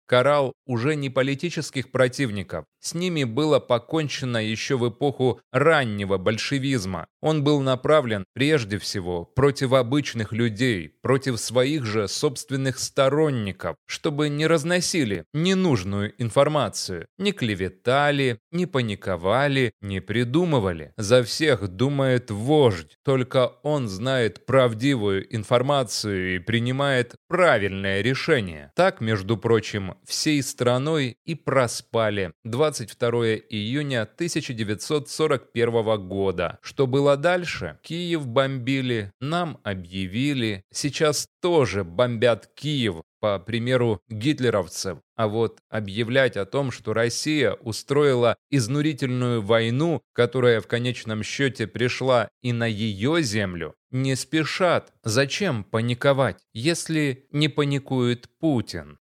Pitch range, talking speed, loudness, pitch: 110-145 Hz, 105 wpm, -23 LUFS, 125 Hz